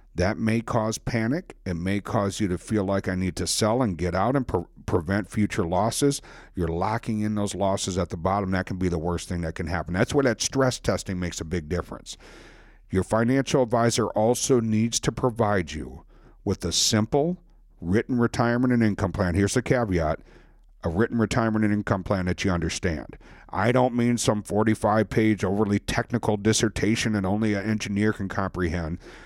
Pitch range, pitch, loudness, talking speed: 95-115 Hz, 105 Hz, -25 LUFS, 190 wpm